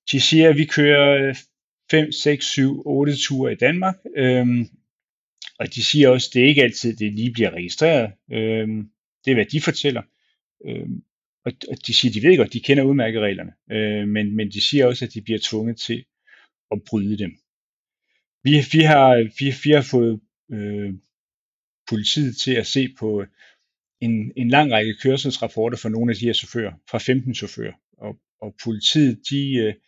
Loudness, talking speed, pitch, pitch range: -19 LUFS, 185 wpm, 120 Hz, 110-140 Hz